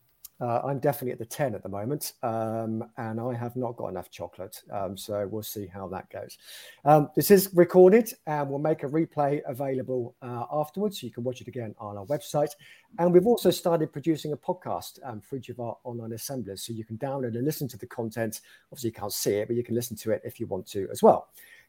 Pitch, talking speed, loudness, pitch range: 125 Hz, 235 wpm, -27 LUFS, 115-150 Hz